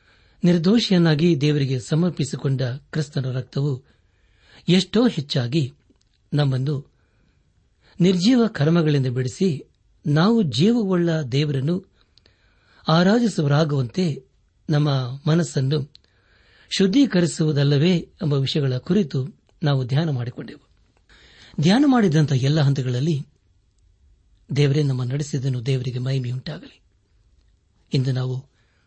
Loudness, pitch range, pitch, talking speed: -21 LUFS, 125-165 Hz, 145 Hz, 70 wpm